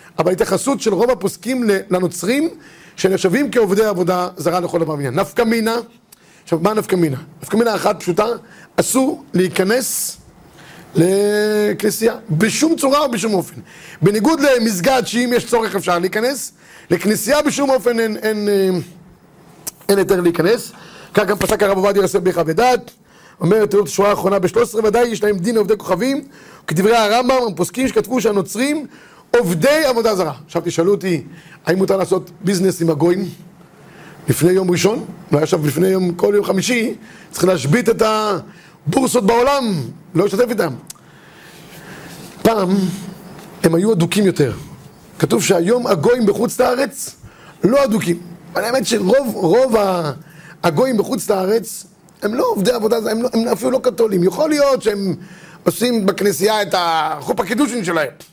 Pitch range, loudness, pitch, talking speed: 175-230 Hz, -17 LUFS, 200 Hz, 140 wpm